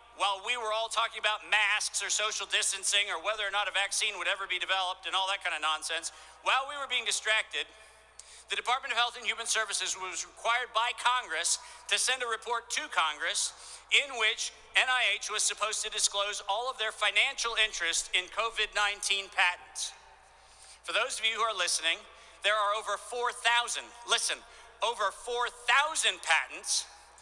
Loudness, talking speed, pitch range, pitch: -29 LUFS, 175 wpm, 200-235 Hz, 215 Hz